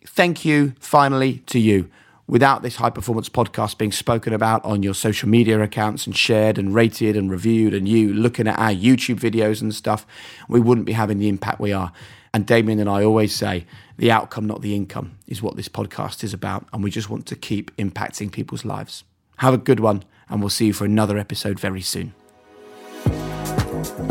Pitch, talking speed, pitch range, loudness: 110 Hz, 200 wpm, 105-115 Hz, -20 LUFS